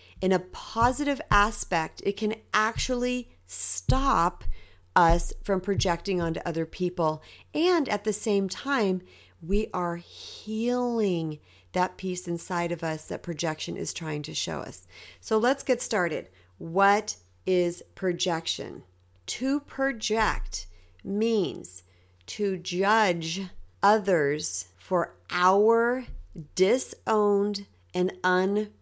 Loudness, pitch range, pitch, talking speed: -27 LUFS, 160-215 Hz, 185 Hz, 110 wpm